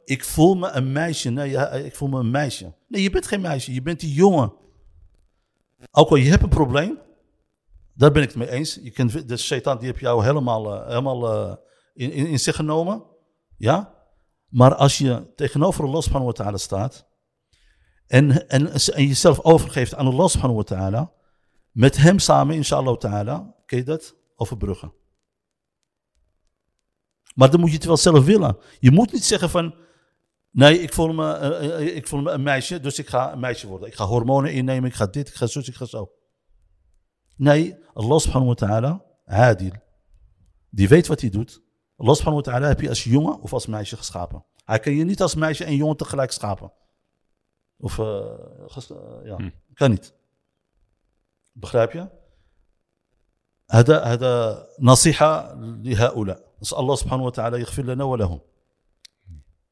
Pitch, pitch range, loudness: 130 Hz, 115-155 Hz, -20 LUFS